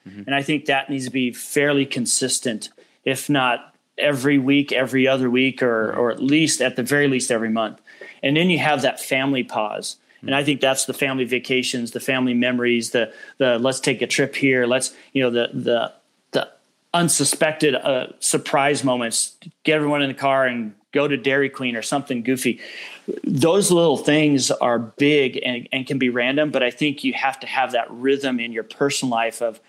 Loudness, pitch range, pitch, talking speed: -20 LUFS, 125-140 Hz, 135 Hz, 195 wpm